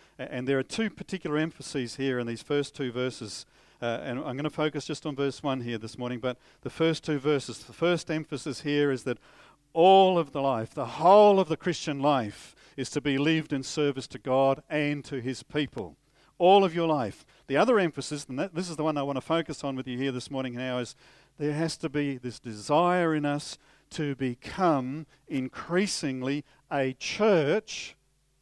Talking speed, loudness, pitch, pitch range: 200 wpm, -28 LUFS, 145 Hz, 130-155 Hz